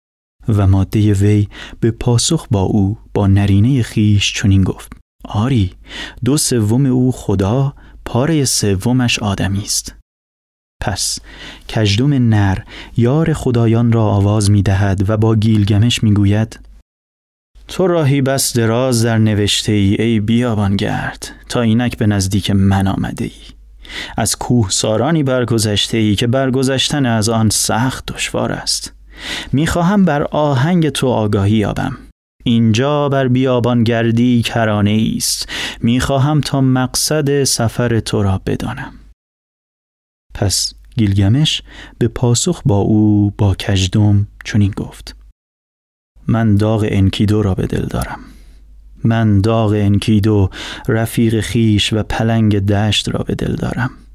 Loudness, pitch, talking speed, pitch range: -15 LUFS, 110 Hz, 125 wpm, 100-120 Hz